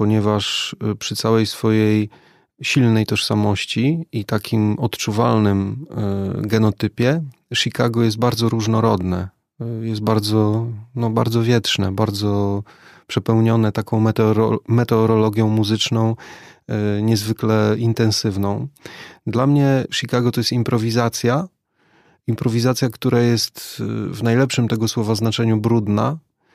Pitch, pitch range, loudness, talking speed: 115 Hz, 110-120 Hz, -19 LUFS, 95 wpm